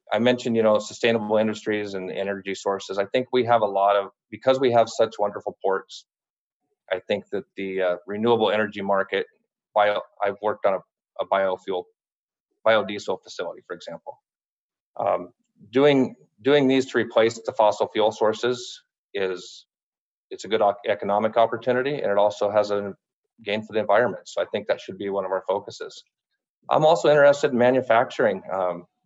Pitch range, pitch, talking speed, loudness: 100-130 Hz, 115 Hz, 170 wpm, -23 LUFS